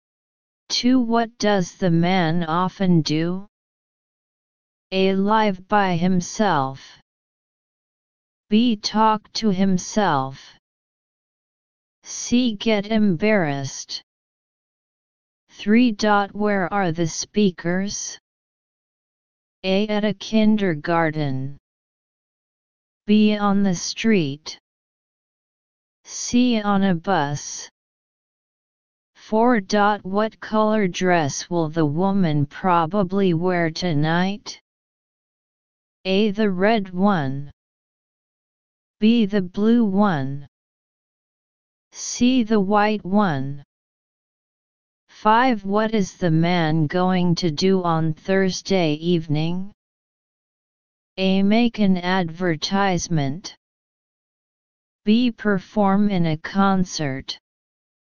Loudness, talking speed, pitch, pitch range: -20 LUFS, 80 wpm, 190 Hz, 170-210 Hz